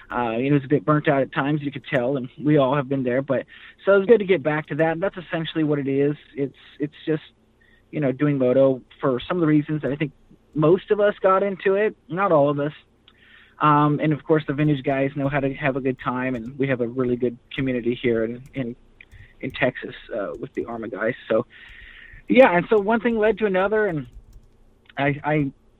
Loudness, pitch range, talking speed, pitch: -22 LUFS, 125-160 Hz, 235 wpm, 145 Hz